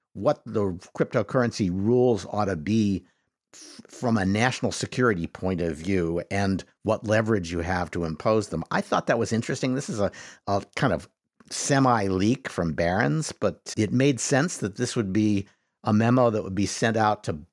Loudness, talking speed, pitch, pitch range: -25 LUFS, 185 wpm, 105 Hz, 95-120 Hz